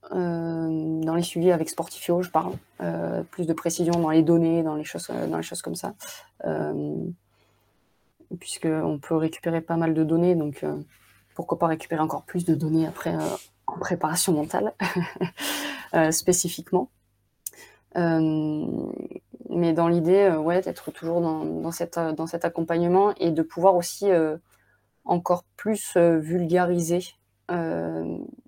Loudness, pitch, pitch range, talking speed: -25 LUFS, 165 Hz, 155-175 Hz, 150 wpm